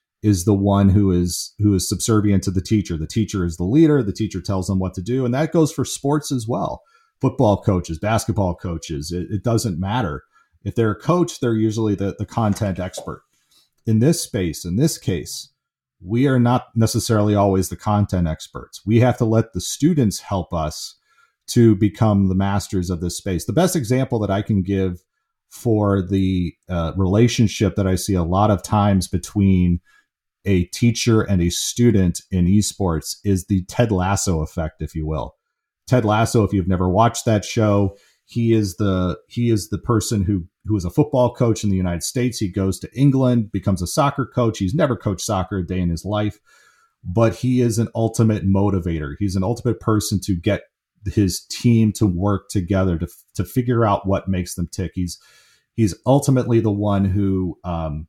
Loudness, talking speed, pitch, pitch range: -20 LUFS, 190 wpm, 105 Hz, 95-115 Hz